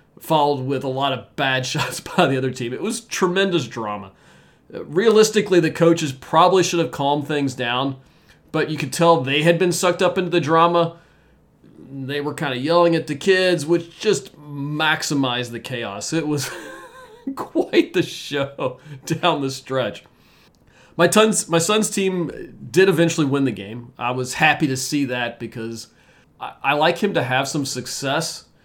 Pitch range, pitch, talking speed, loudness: 130-175 Hz, 155 Hz, 170 wpm, -20 LUFS